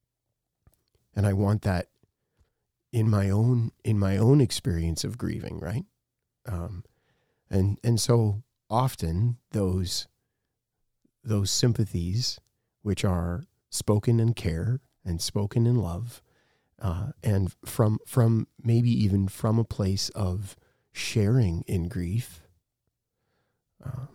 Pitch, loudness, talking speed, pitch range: 110 Hz, -27 LUFS, 110 wpm, 95-120 Hz